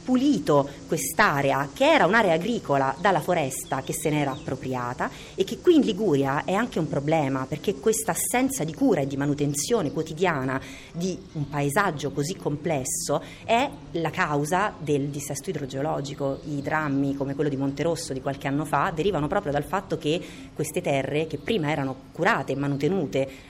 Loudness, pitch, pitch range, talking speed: -25 LUFS, 150 Hz, 140-180 Hz, 165 wpm